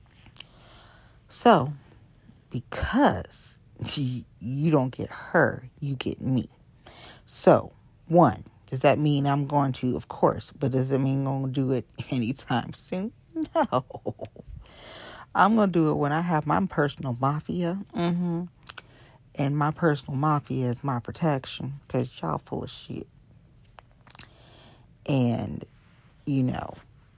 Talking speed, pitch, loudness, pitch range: 130 wpm, 135 Hz, -26 LUFS, 125-150 Hz